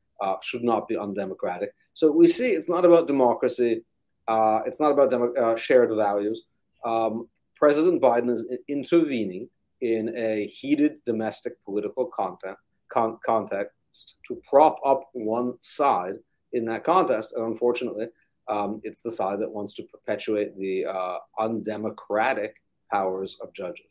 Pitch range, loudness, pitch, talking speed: 110-140 Hz, -24 LUFS, 120 Hz, 145 wpm